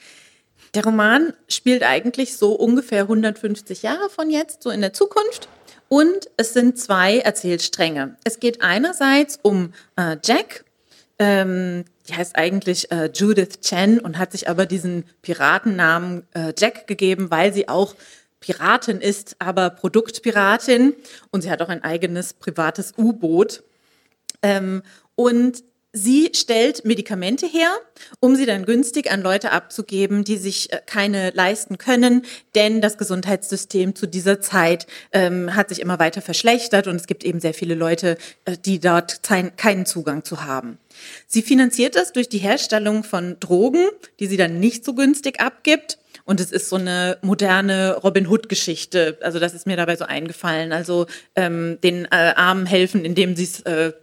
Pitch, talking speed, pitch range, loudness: 195 Hz, 155 wpm, 180-230 Hz, -19 LUFS